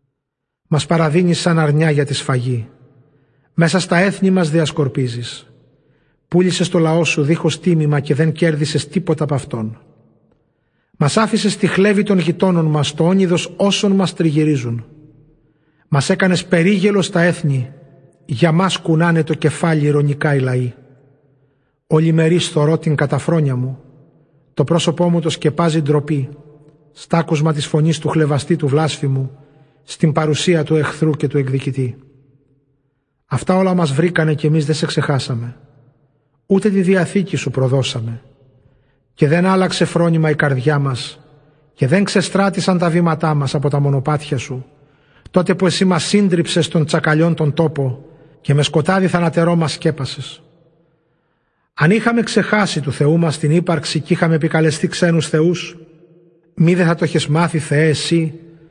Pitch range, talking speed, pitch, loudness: 145-170 Hz, 145 wpm, 155 Hz, -16 LUFS